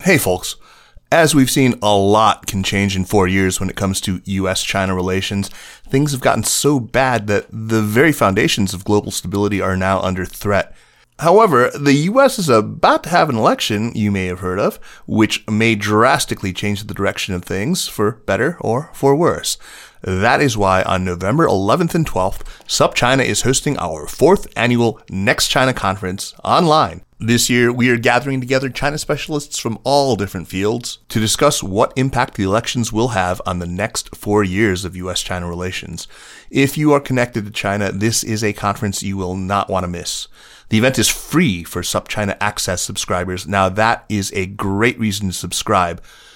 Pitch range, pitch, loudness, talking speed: 95-120 Hz, 105 Hz, -17 LUFS, 180 wpm